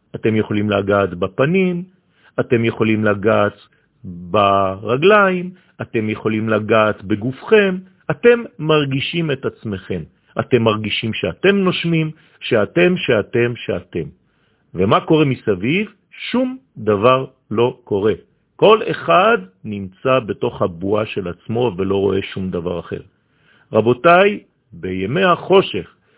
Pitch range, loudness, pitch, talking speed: 105-170 Hz, -17 LUFS, 120 Hz, 105 wpm